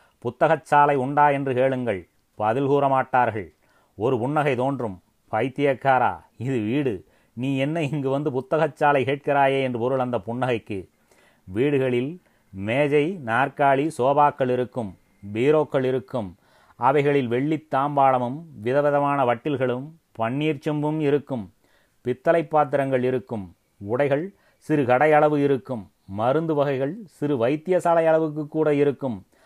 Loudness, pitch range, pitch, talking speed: -23 LUFS, 125-145 Hz, 135 Hz, 110 wpm